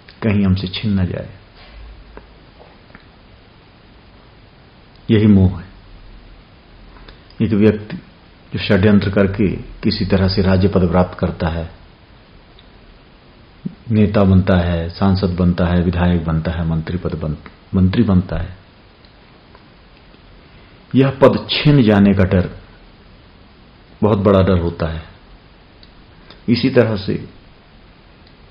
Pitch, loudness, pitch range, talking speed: 95 Hz, -16 LUFS, 85-105 Hz, 105 wpm